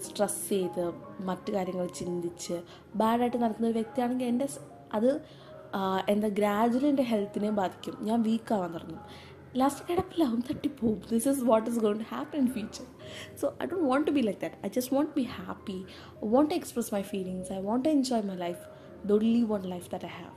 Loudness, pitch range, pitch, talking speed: -30 LUFS, 195-255 Hz, 220 Hz, 185 wpm